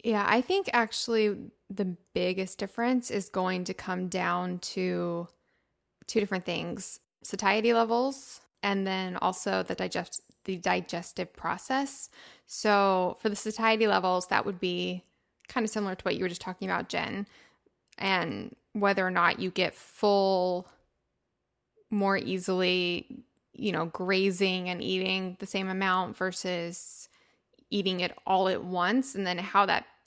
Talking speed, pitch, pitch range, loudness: 145 wpm, 190 Hz, 185-215 Hz, -29 LUFS